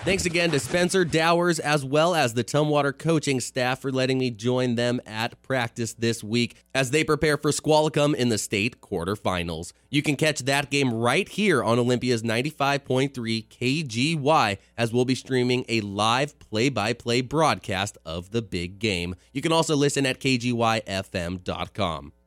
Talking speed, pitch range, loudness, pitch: 165 wpm, 115-145 Hz, -24 LUFS, 125 Hz